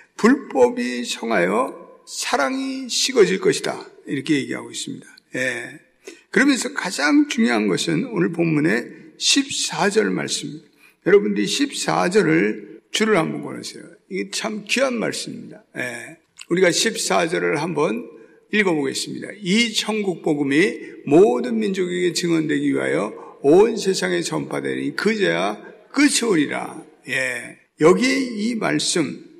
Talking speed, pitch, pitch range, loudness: 265 characters per minute, 235 Hz, 190-290 Hz, -20 LUFS